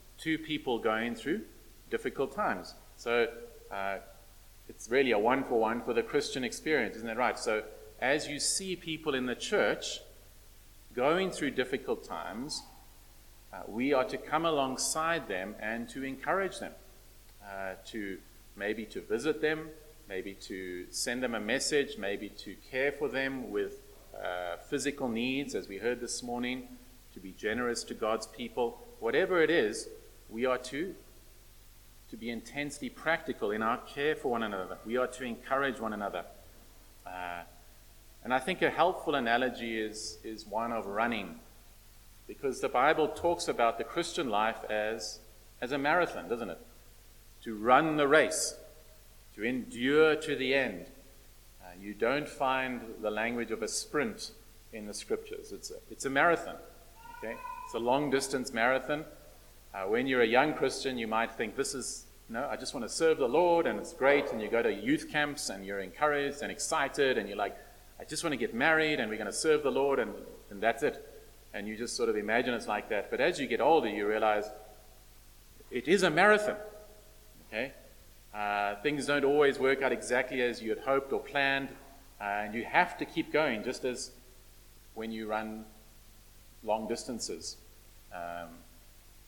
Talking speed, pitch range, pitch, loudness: 175 wpm, 105-155 Hz, 125 Hz, -32 LUFS